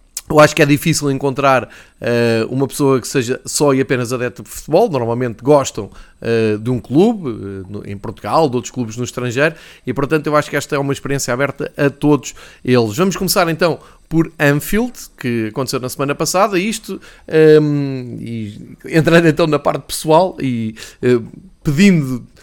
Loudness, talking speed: -16 LUFS, 175 wpm